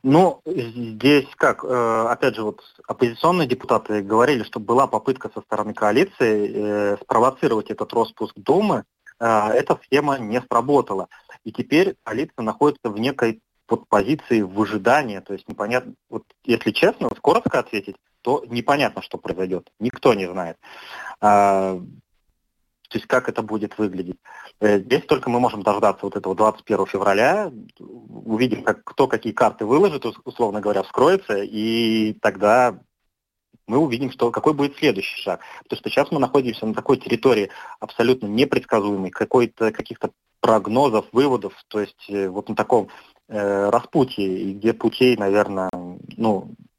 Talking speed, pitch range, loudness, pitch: 130 wpm, 105-125 Hz, -21 LUFS, 110 Hz